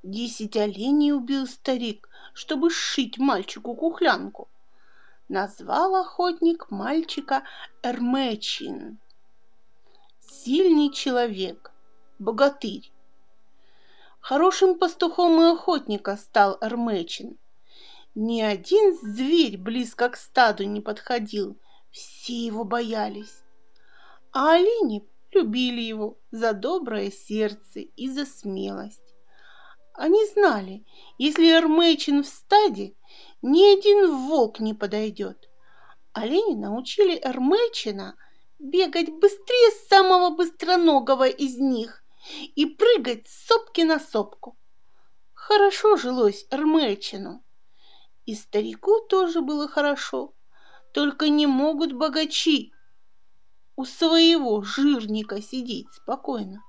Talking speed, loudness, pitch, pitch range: 90 wpm, -22 LUFS, 270 Hz, 215-335 Hz